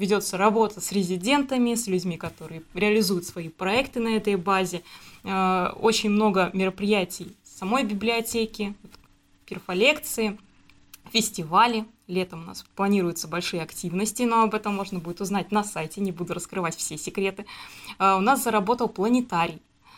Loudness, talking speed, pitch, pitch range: -25 LUFS, 130 wpm, 200 Hz, 180-220 Hz